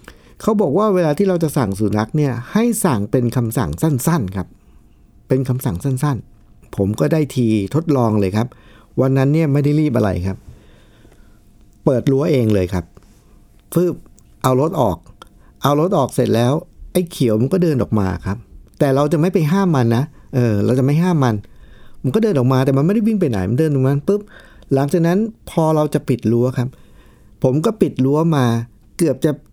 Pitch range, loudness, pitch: 110-160 Hz, -17 LUFS, 135 Hz